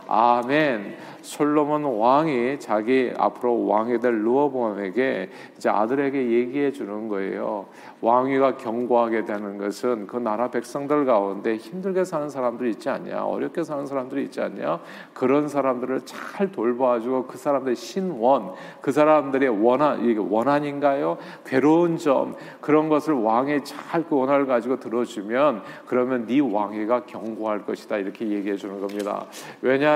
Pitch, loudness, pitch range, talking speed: 130 Hz, -23 LUFS, 115-145 Hz, 315 characters per minute